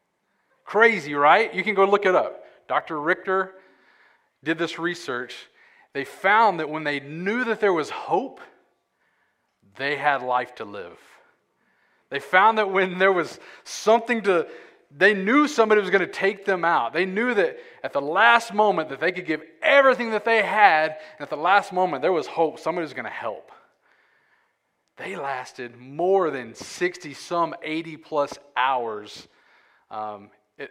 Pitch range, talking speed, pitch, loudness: 150-215 Hz, 160 wpm, 180 Hz, -22 LUFS